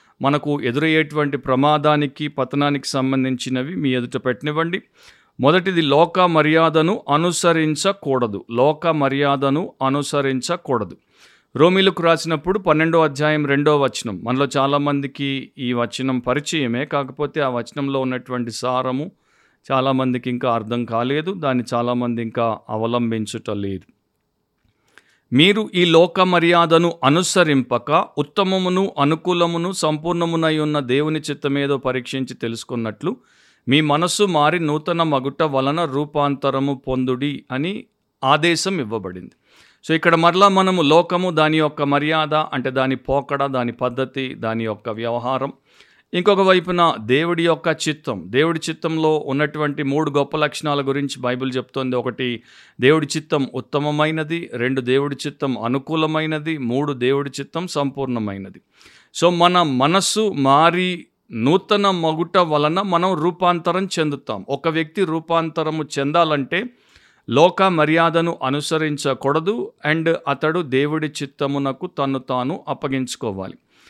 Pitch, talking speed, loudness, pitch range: 145 Hz, 105 wpm, -19 LUFS, 130-165 Hz